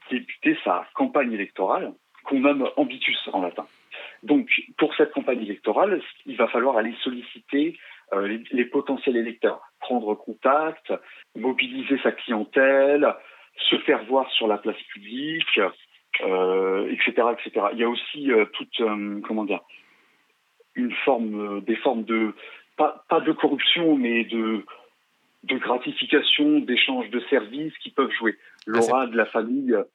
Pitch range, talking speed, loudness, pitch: 115-155 Hz, 140 wpm, -23 LUFS, 135 Hz